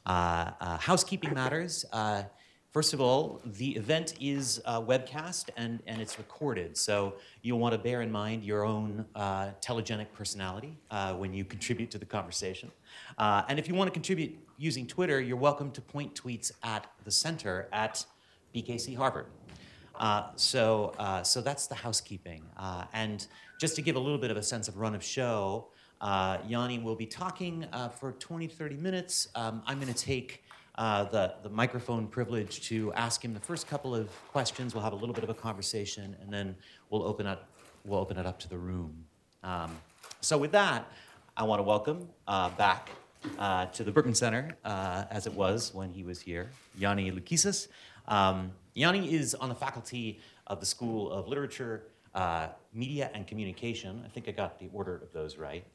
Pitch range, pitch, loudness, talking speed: 100-135 Hz, 110 Hz, -33 LUFS, 185 wpm